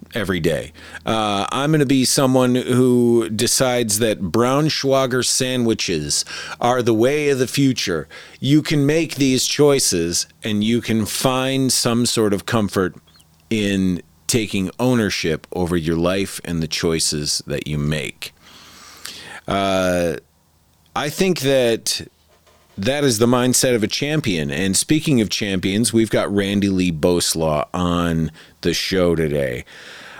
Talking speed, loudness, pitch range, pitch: 135 wpm, -18 LUFS, 90-130 Hz, 110 Hz